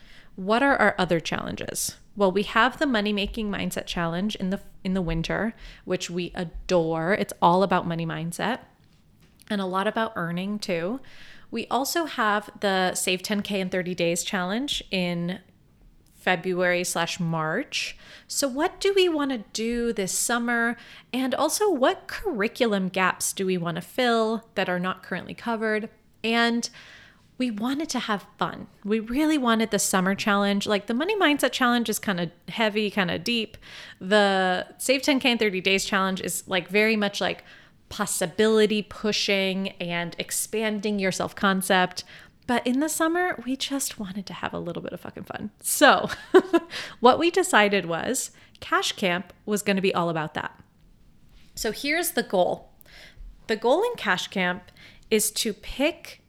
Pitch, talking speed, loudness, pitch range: 210 Hz, 165 wpm, -25 LUFS, 185-235 Hz